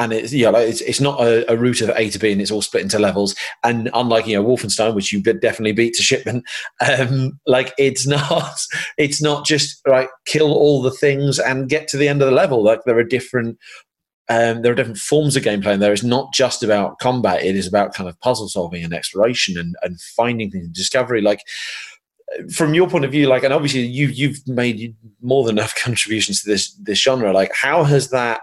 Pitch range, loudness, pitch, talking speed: 110-140 Hz, -17 LUFS, 125 Hz, 230 wpm